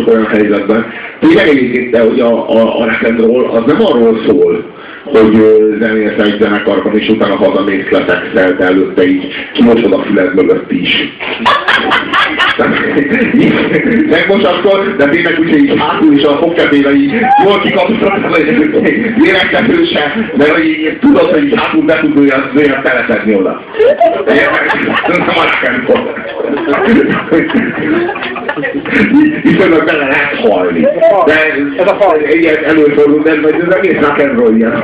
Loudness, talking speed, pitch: -9 LUFS, 150 wpm, 150 Hz